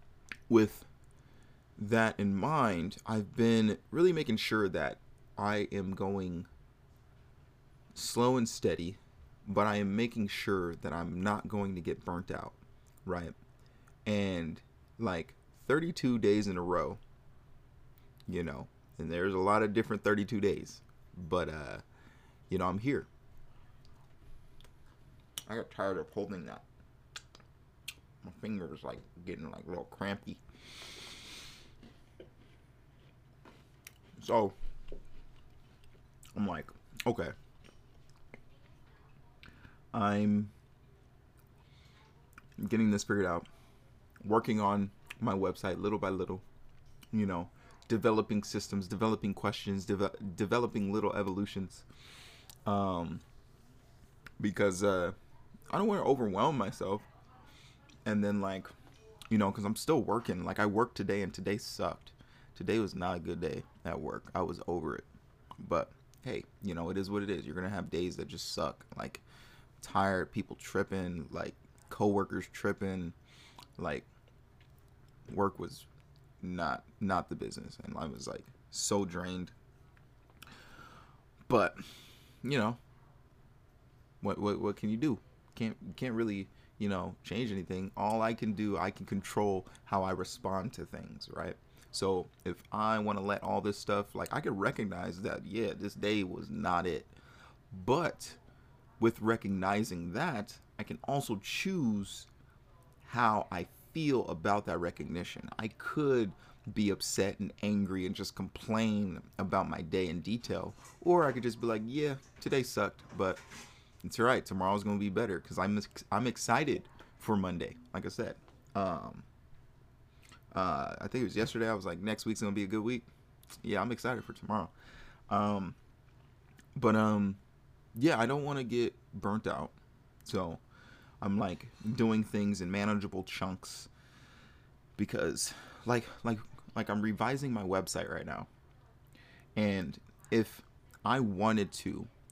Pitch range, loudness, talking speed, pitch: 100-120 Hz, -35 LUFS, 140 wpm, 105 Hz